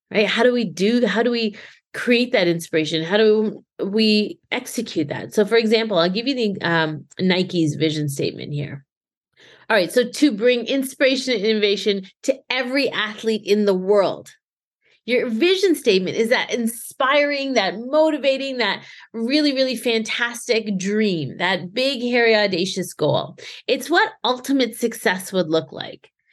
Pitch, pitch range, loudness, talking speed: 225 Hz, 195-250 Hz, -20 LUFS, 155 wpm